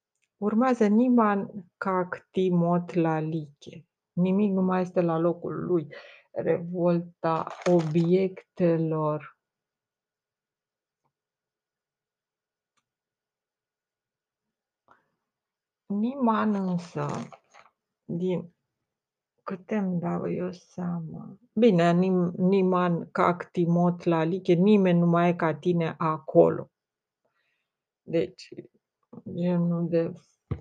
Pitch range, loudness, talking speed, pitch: 170-190 Hz, -26 LUFS, 75 wpm, 175 Hz